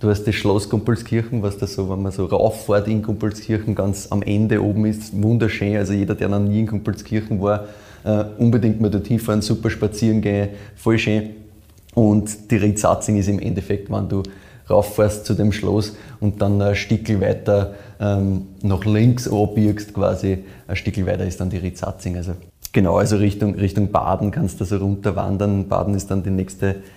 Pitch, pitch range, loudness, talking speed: 105 Hz, 100-110 Hz, -20 LUFS, 180 wpm